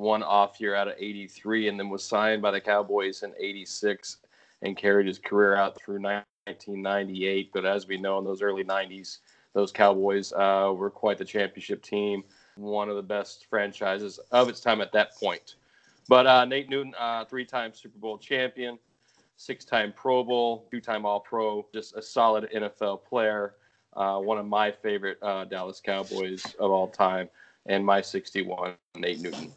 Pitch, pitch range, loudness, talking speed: 100 Hz, 100-110 Hz, -27 LUFS, 180 wpm